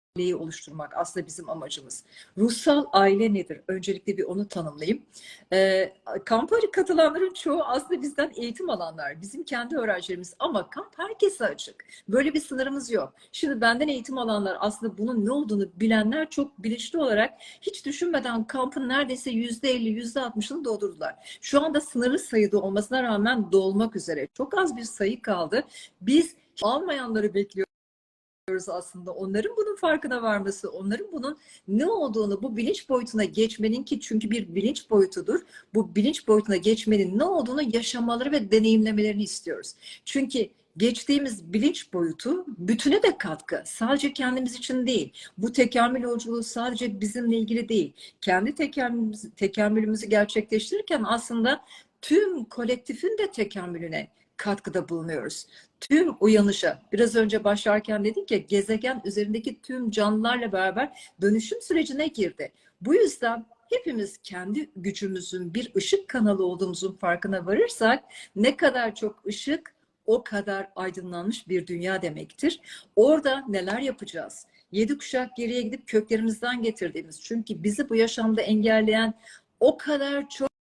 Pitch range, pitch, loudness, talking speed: 200-275 Hz, 225 Hz, -26 LUFS, 135 wpm